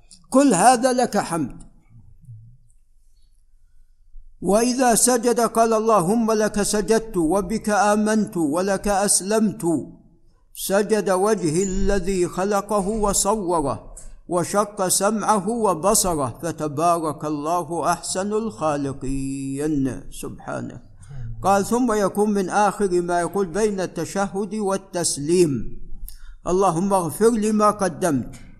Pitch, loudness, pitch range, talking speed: 190 Hz, -21 LUFS, 150-210 Hz, 90 wpm